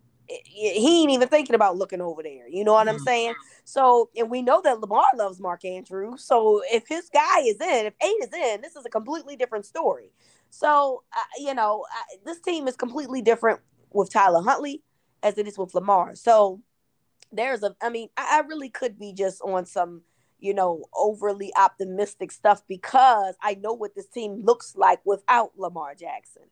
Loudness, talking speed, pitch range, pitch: -23 LUFS, 190 wpm, 200-280 Hz, 225 Hz